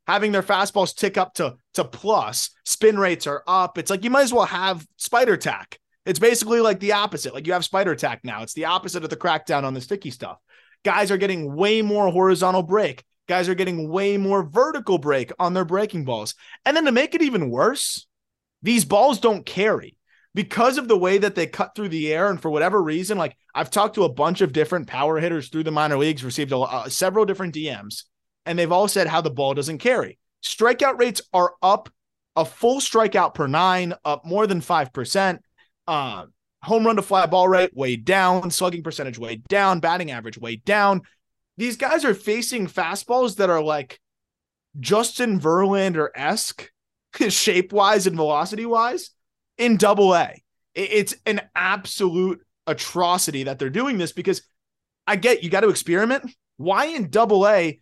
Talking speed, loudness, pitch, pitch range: 190 wpm, -21 LUFS, 185 Hz, 160-210 Hz